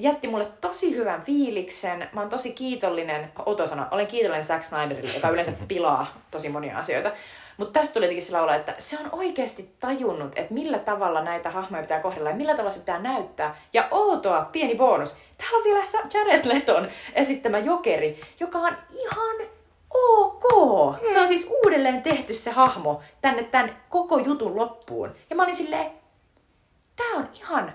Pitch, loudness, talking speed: 260 Hz, -24 LUFS, 165 wpm